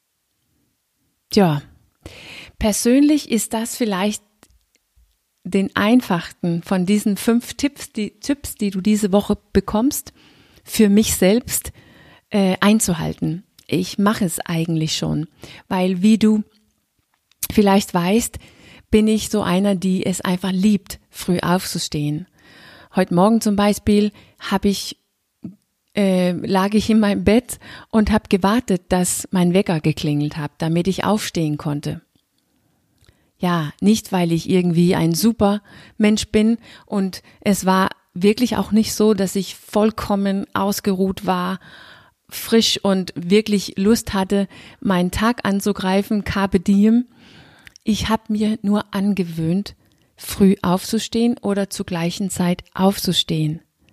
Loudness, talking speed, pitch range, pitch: -19 LUFS, 120 wpm, 180-215 Hz, 200 Hz